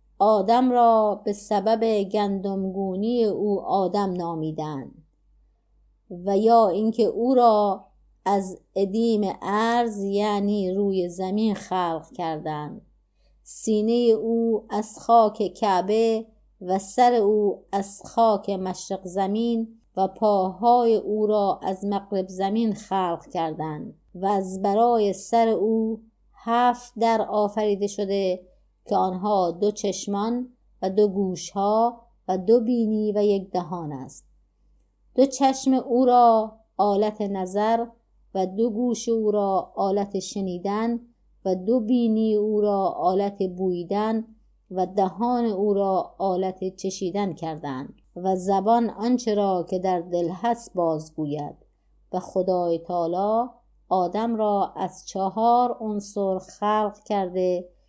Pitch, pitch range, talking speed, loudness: 205 Hz, 185-225 Hz, 115 wpm, -24 LUFS